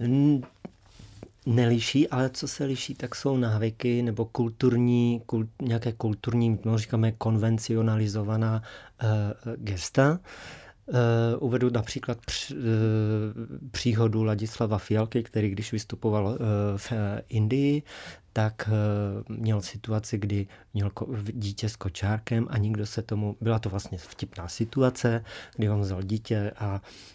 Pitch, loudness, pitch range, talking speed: 110 Hz, -28 LUFS, 105-120 Hz, 125 wpm